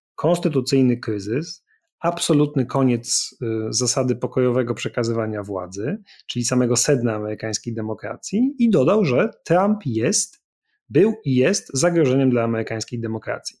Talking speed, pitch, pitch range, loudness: 115 wpm, 130 Hz, 115-165 Hz, -21 LUFS